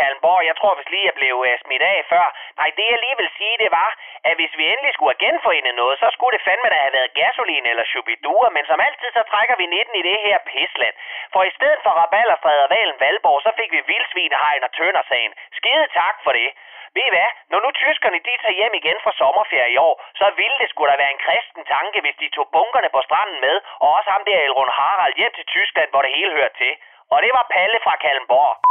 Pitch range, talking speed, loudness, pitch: 180-300 Hz, 240 wpm, -17 LUFS, 230 Hz